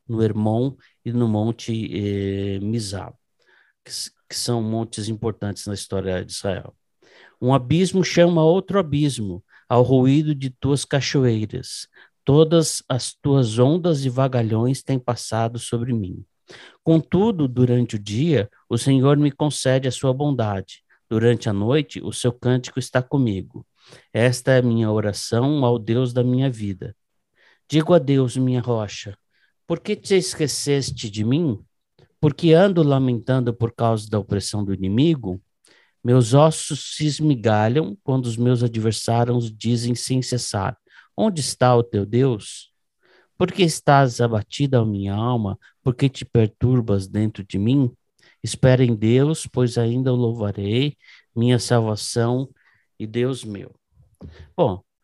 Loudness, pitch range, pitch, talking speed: -21 LUFS, 110-135 Hz, 125 Hz, 140 wpm